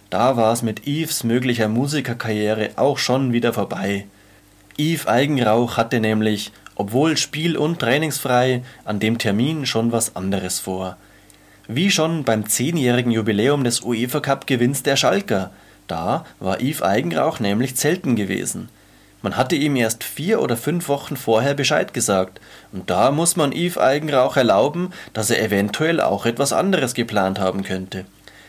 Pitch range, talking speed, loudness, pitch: 105-140 Hz, 145 wpm, -20 LUFS, 120 Hz